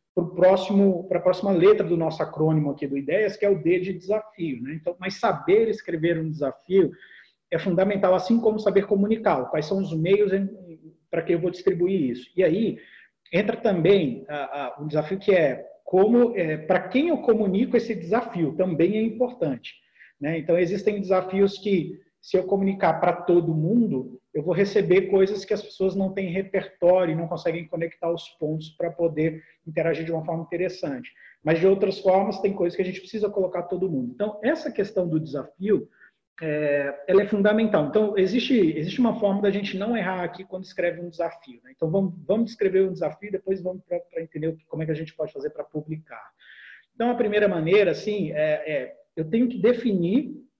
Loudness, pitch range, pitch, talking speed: -24 LUFS, 165-205 Hz, 185 Hz, 190 wpm